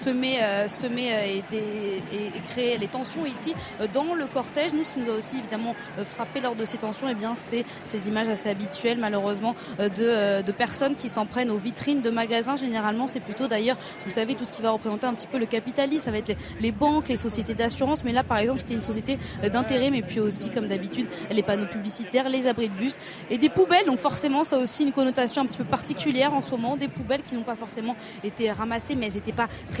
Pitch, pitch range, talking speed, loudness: 235 Hz, 215-260 Hz, 235 wpm, -26 LUFS